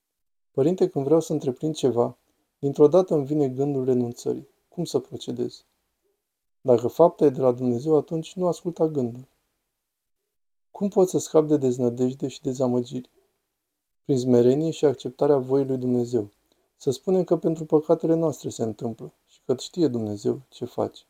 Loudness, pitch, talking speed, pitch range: -24 LUFS, 140 Hz, 155 wpm, 125-165 Hz